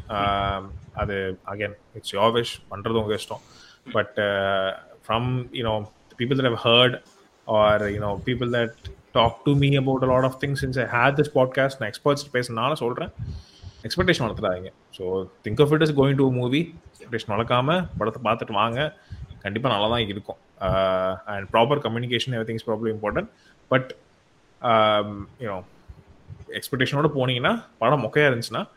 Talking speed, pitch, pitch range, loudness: 140 wpm, 115 Hz, 105-130 Hz, -23 LUFS